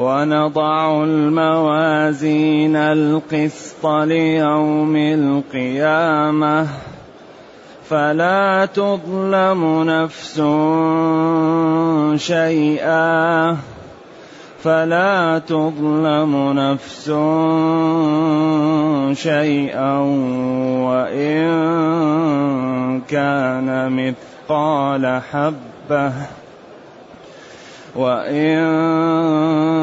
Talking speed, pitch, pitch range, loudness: 35 wpm, 155 Hz, 140-160 Hz, -17 LUFS